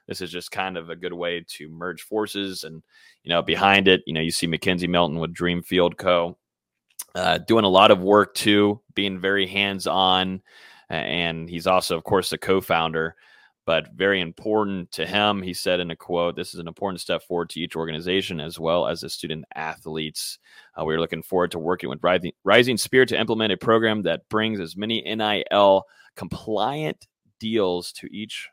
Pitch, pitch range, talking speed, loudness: 90 Hz, 85-100 Hz, 190 wpm, -22 LUFS